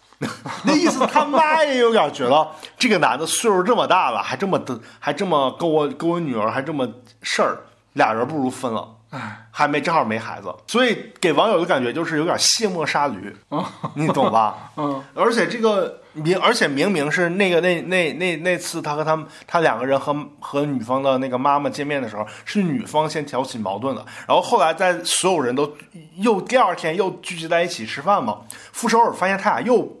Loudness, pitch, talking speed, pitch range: -20 LUFS, 165 Hz, 300 characters per minute, 140-195 Hz